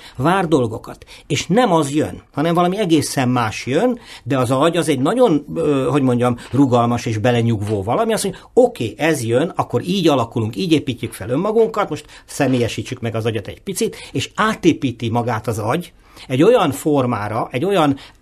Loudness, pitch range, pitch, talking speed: -18 LUFS, 120-165 Hz, 135 Hz, 175 wpm